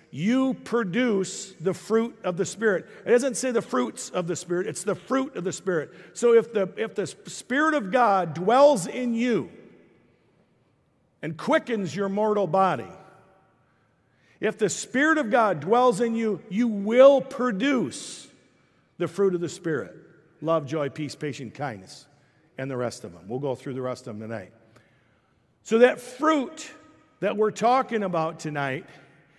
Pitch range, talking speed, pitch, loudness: 150-235 Hz, 160 wpm, 195 Hz, -25 LUFS